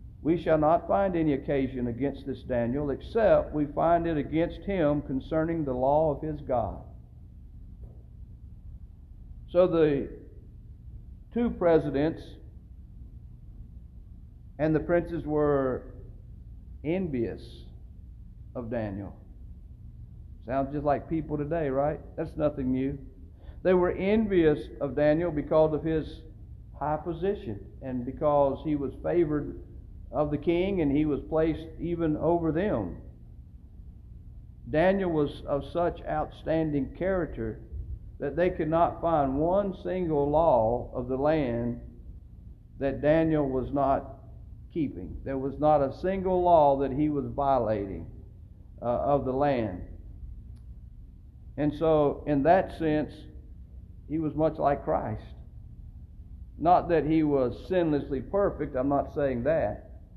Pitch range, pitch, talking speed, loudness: 120-160 Hz, 145 Hz, 120 wpm, -27 LUFS